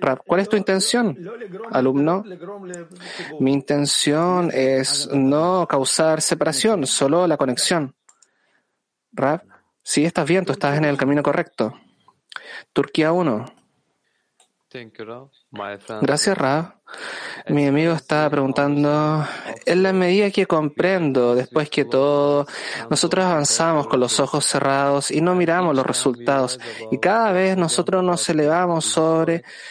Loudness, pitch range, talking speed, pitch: -19 LUFS, 140-180 Hz, 120 wpm, 150 Hz